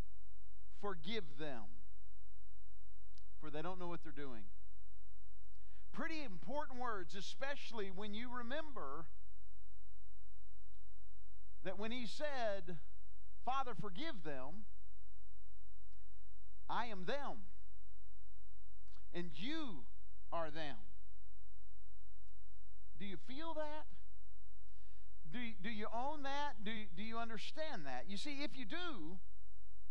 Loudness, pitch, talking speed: -47 LUFS, 95 Hz, 100 wpm